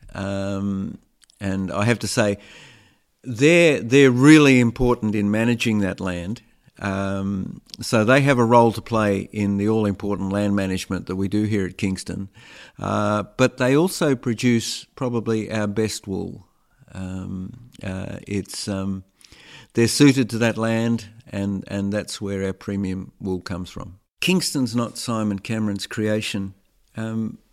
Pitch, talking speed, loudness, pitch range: 105 Hz, 145 wpm, -21 LUFS, 100-120 Hz